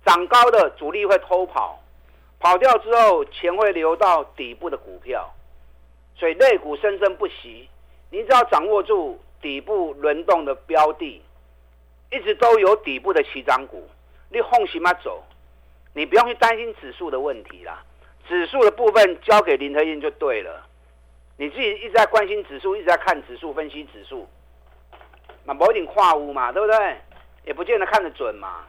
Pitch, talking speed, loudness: 180 Hz, 250 characters per minute, -19 LUFS